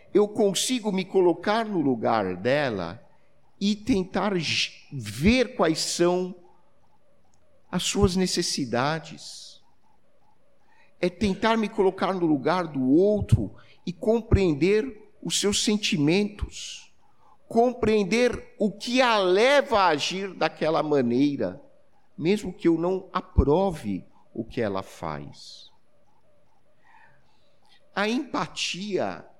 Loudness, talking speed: -24 LUFS, 100 wpm